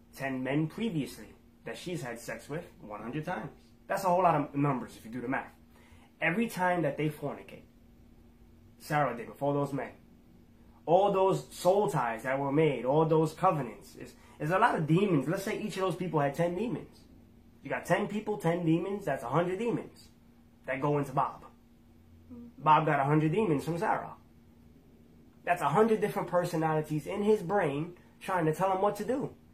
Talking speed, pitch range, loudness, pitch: 185 wpm, 140-190 Hz, -30 LUFS, 160 Hz